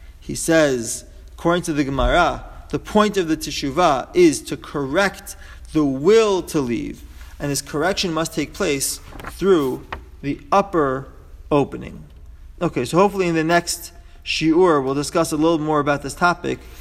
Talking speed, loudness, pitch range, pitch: 155 wpm, -20 LUFS, 125-170 Hz, 150 Hz